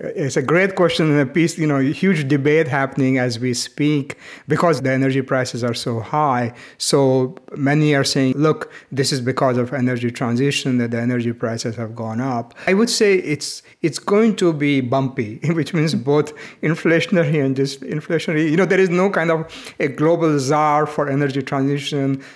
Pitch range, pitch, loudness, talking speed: 130-160 Hz, 145 Hz, -19 LUFS, 190 wpm